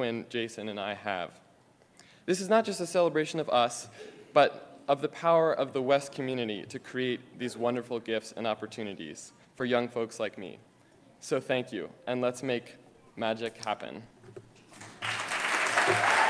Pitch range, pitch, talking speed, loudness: 115-140 Hz, 120 Hz, 145 wpm, -30 LUFS